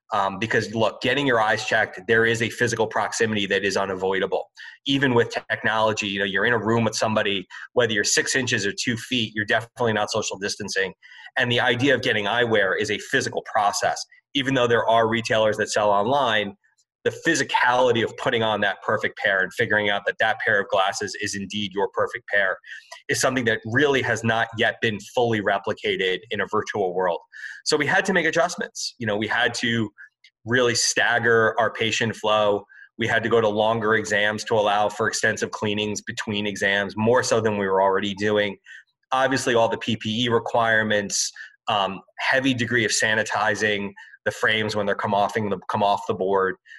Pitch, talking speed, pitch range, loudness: 110 Hz, 190 wpm, 105-120 Hz, -22 LUFS